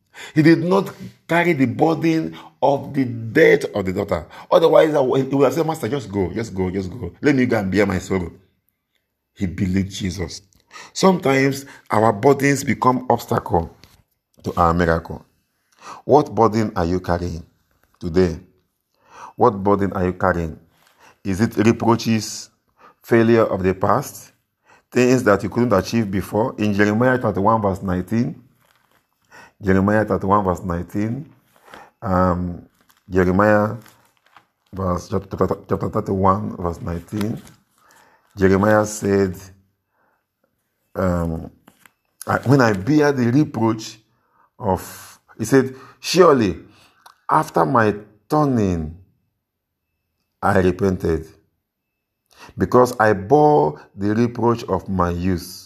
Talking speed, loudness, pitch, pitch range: 115 wpm, -19 LUFS, 105 Hz, 95-120 Hz